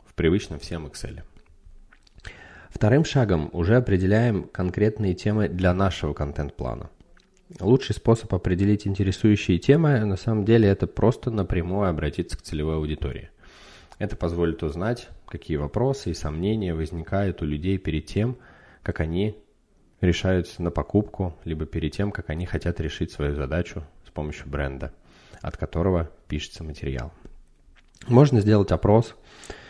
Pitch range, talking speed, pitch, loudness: 80-105 Hz, 125 wpm, 90 Hz, -24 LUFS